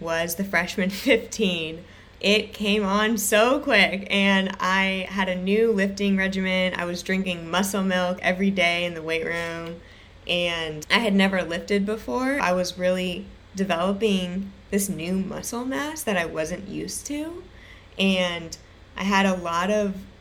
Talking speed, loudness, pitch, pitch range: 155 wpm, -23 LUFS, 190 Hz, 175-205 Hz